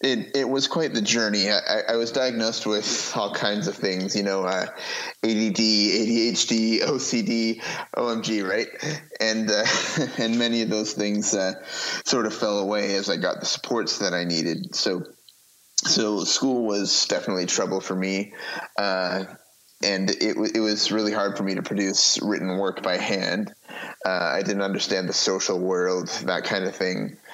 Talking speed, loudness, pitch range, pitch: 170 wpm, -23 LUFS, 95-110 Hz, 105 Hz